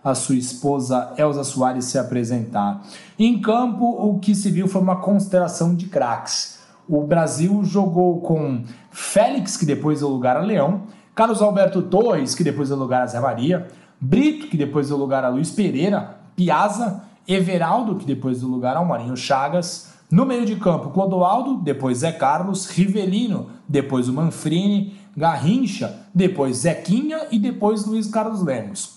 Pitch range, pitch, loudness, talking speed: 140-205 Hz, 180 Hz, -20 LUFS, 155 wpm